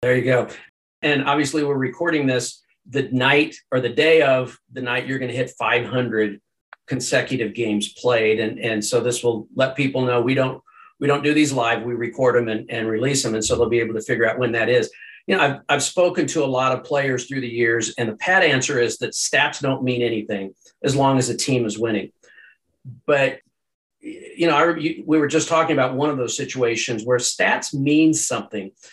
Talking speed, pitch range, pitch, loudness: 215 wpm, 120-145 Hz, 130 Hz, -20 LUFS